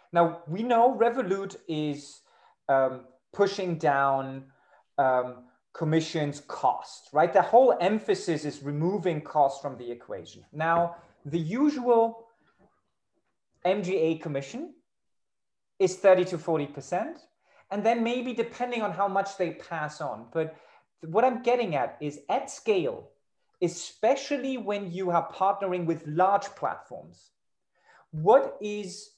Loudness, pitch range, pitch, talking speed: -27 LUFS, 150-210 Hz, 175 Hz, 120 wpm